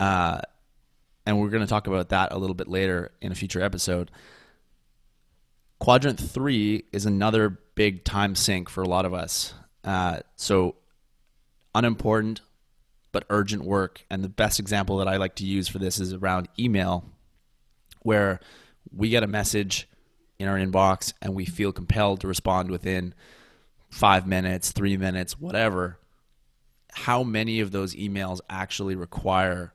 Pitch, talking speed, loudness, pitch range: 95 Hz, 150 wpm, -25 LUFS, 90-105 Hz